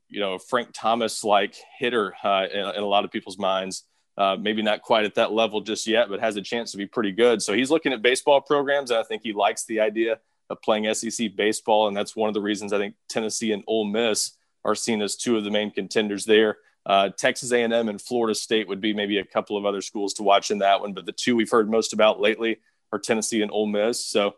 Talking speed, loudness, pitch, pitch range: 250 wpm, -23 LUFS, 110 Hz, 100-115 Hz